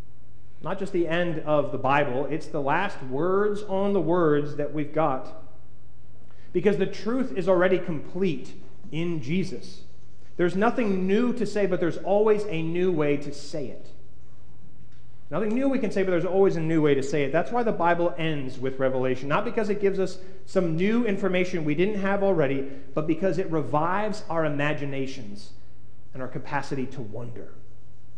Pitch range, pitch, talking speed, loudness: 145-195 Hz, 165 Hz, 175 wpm, -26 LUFS